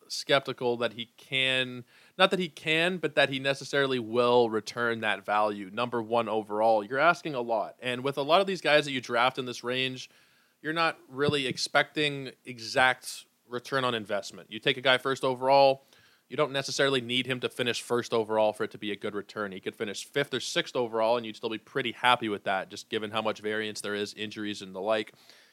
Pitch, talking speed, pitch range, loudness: 125 Hz, 215 wpm, 110-140 Hz, -28 LUFS